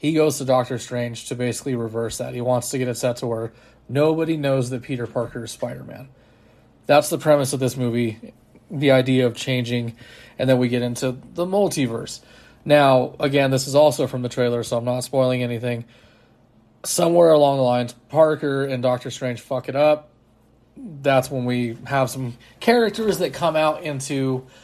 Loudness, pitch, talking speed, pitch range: -21 LUFS, 130 Hz, 185 wpm, 120-145 Hz